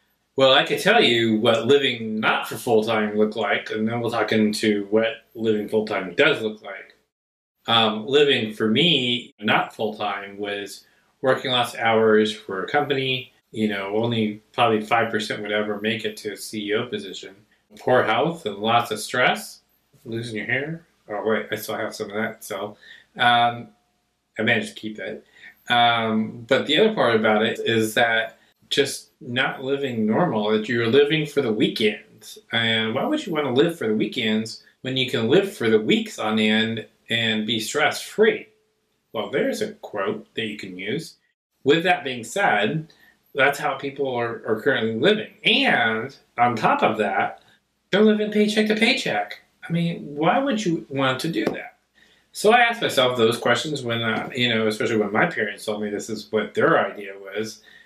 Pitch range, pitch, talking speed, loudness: 110-140 Hz, 115 Hz, 185 wpm, -22 LUFS